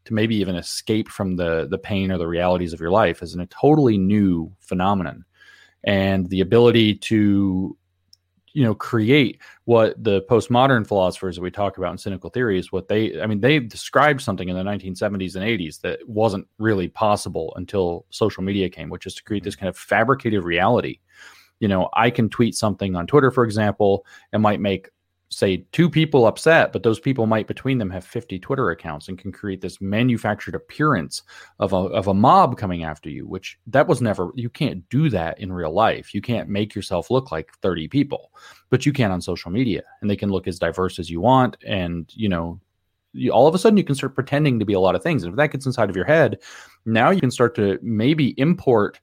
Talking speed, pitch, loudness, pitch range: 215 wpm, 100 Hz, -20 LUFS, 95-115 Hz